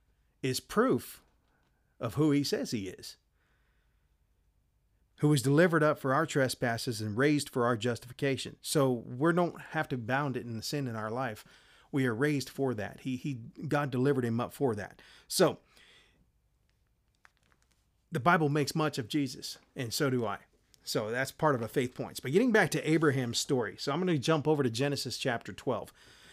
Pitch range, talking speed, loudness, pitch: 120-150 Hz, 180 wpm, -31 LUFS, 135 Hz